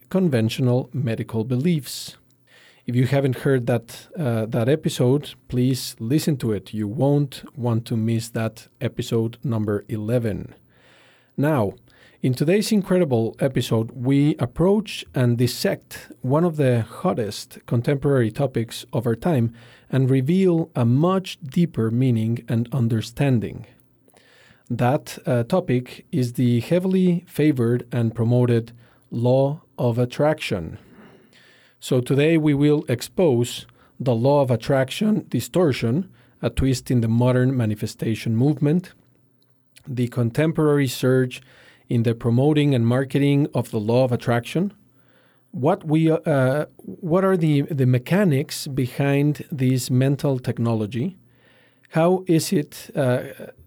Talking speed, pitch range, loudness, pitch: 120 wpm, 120-150 Hz, -22 LUFS, 130 Hz